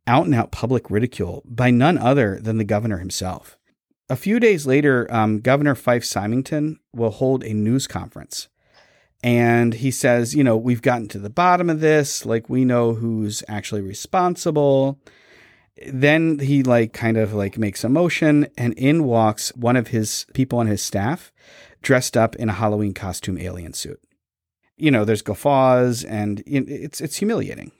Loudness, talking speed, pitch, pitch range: -20 LUFS, 170 wpm, 120 Hz, 110-140 Hz